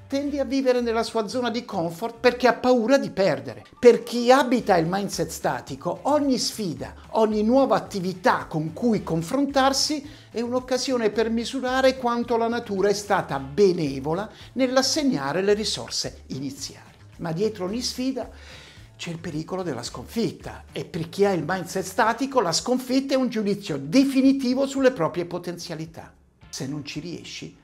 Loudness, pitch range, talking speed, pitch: -24 LUFS, 170-255 Hz, 150 wpm, 215 Hz